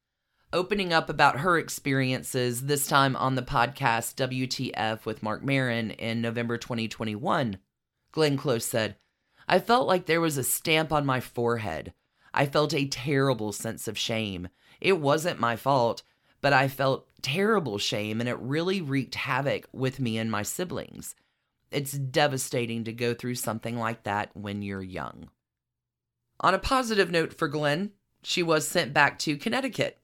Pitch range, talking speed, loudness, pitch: 115-150 Hz, 160 wpm, -27 LUFS, 130 Hz